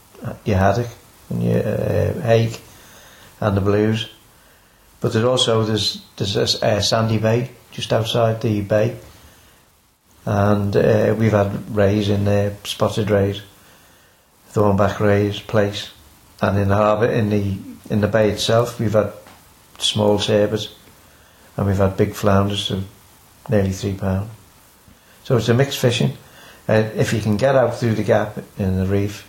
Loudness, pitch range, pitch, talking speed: -19 LUFS, 100-110 Hz, 105 Hz, 150 wpm